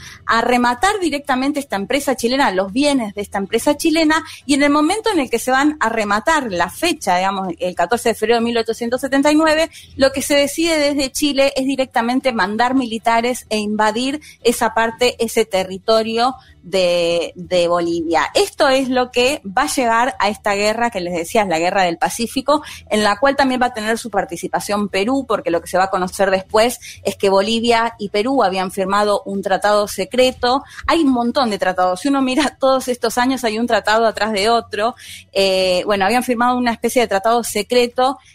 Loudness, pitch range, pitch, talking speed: -17 LUFS, 200-265 Hz, 230 Hz, 190 wpm